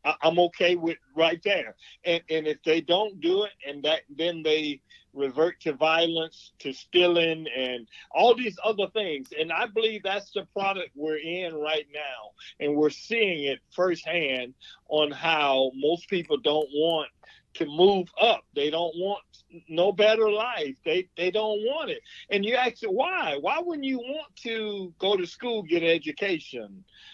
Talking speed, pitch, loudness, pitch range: 170 wpm, 170 Hz, -26 LUFS, 155-210 Hz